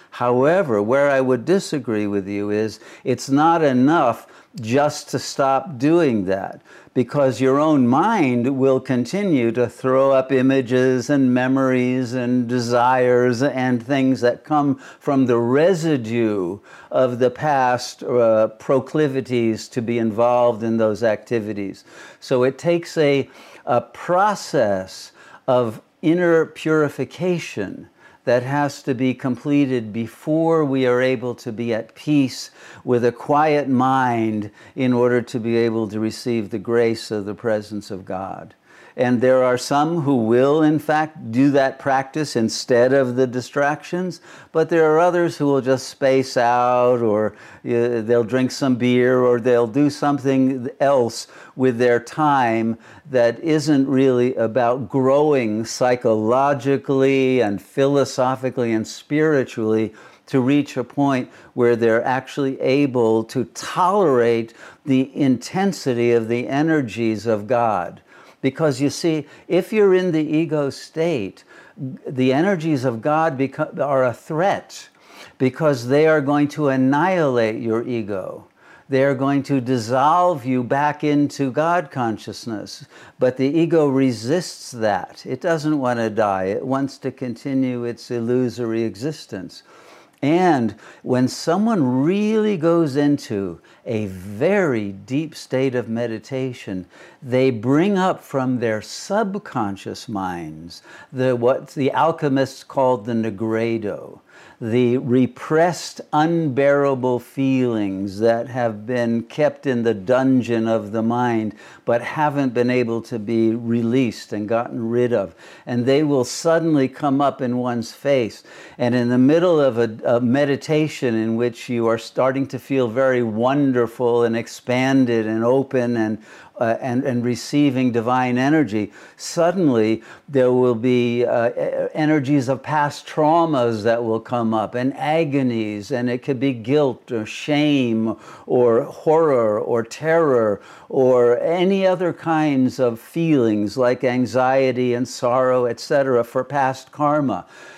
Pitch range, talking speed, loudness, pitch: 120-145 Hz, 135 wpm, -19 LUFS, 130 Hz